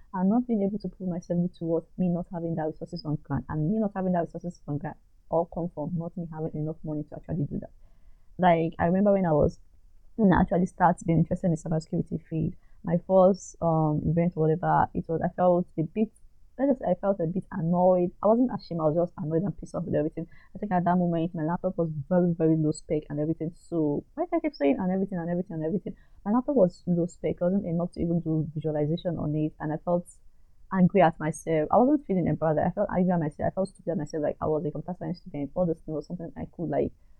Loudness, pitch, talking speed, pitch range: -27 LUFS, 170 Hz, 255 wpm, 155-185 Hz